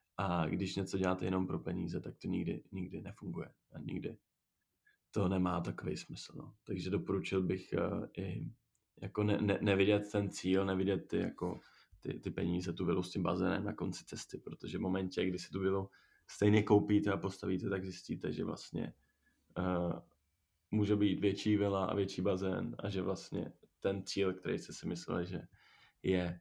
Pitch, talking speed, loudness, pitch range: 95 Hz, 175 wpm, -37 LUFS, 90-100 Hz